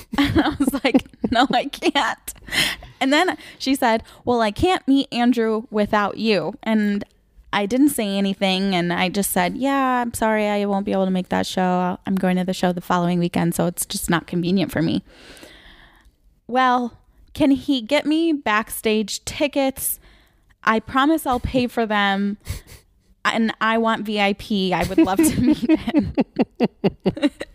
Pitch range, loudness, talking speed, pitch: 195-270 Hz, -20 LUFS, 165 wpm, 220 Hz